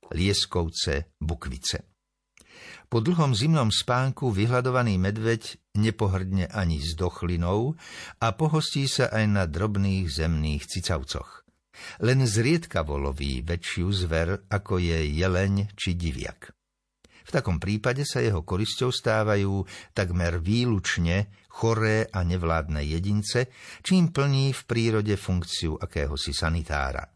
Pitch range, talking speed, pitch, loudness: 85-115 Hz, 110 wpm, 100 Hz, -26 LUFS